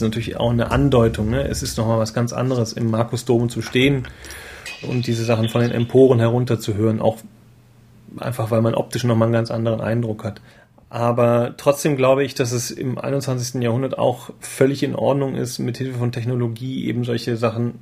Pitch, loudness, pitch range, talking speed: 120 Hz, -20 LUFS, 115-125 Hz, 180 wpm